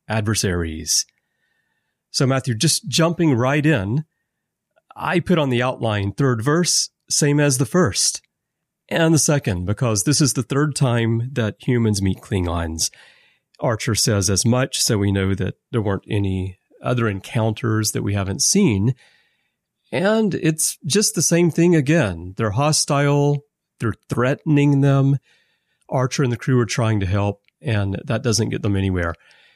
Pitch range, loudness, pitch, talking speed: 105-150 Hz, -19 LUFS, 125 Hz, 150 wpm